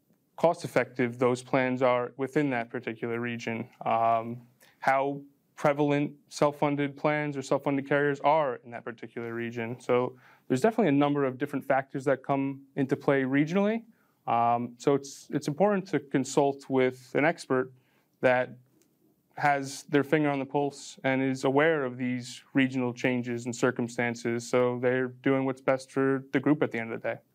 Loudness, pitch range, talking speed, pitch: -28 LUFS, 125-145 Hz, 170 wpm, 135 Hz